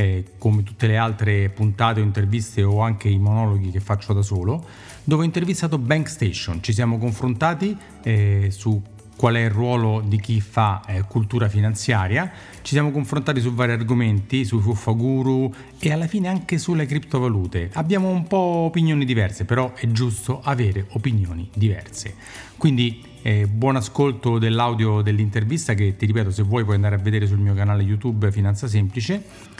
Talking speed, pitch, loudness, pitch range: 160 wpm, 115 Hz, -21 LUFS, 105-130 Hz